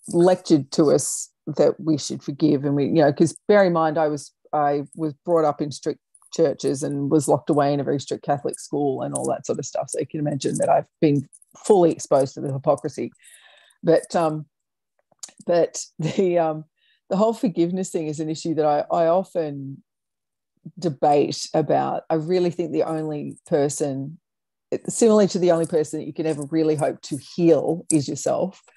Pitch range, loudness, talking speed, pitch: 150-170 Hz, -22 LUFS, 190 wpm, 155 Hz